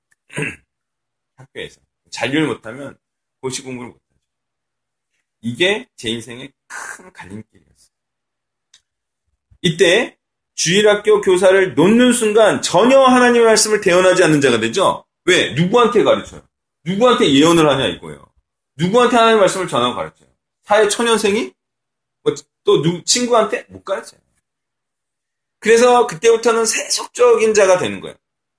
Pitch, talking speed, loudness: 185 Hz, 295 characters per minute, -14 LUFS